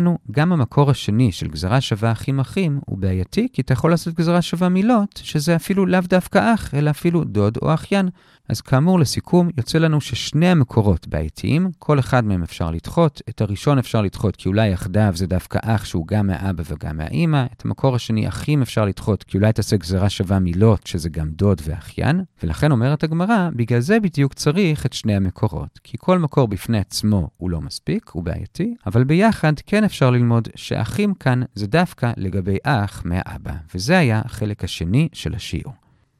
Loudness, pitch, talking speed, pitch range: -19 LUFS, 120 Hz, 180 wpm, 100-155 Hz